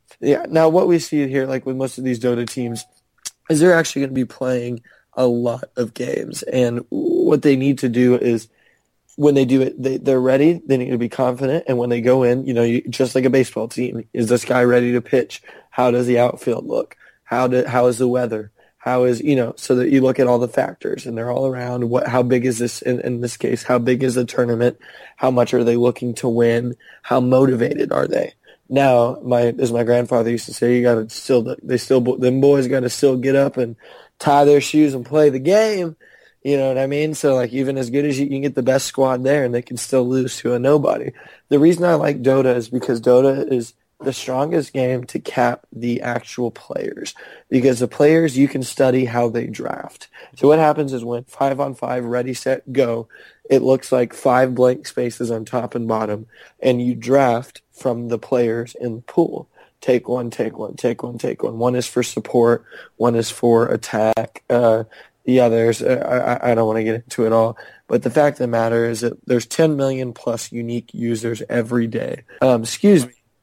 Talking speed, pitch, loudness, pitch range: 220 wpm, 125 Hz, -18 LUFS, 120-135 Hz